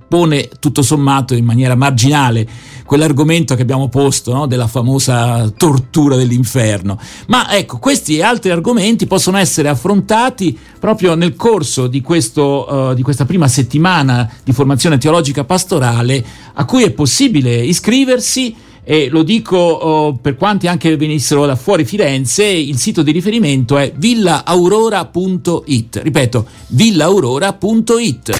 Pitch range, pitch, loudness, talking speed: 130-180 Hz, 150 Hz, -12 LUFS, 130 wpm